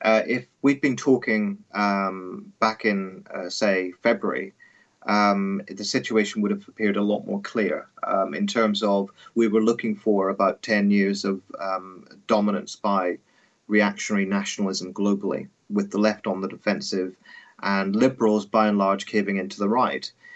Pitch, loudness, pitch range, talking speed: 105 Hz, -24 LUFS, 100-115 Hz, 160 wpm